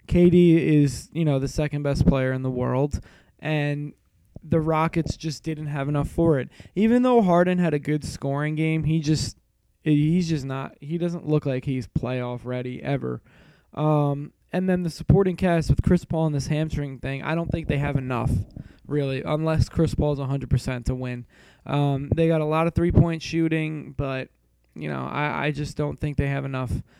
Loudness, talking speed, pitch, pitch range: -24 LUFS, 190 wpm, 145 Hz, 130-160 Hz